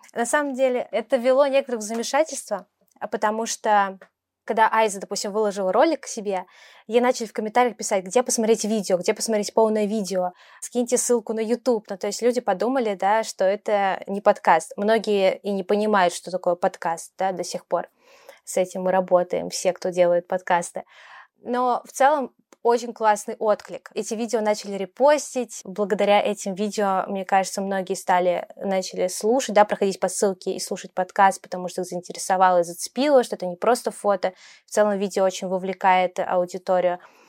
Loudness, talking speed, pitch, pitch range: -23 LUFS, 165 wpm, 205 Hz, 190-235 Hz